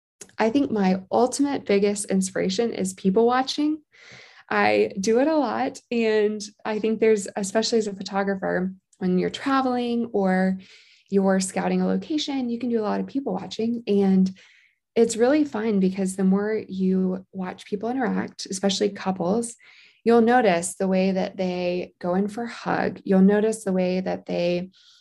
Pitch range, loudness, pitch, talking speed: 190-230 Hz, -23 LUFS, 200 Hz, 165 wpm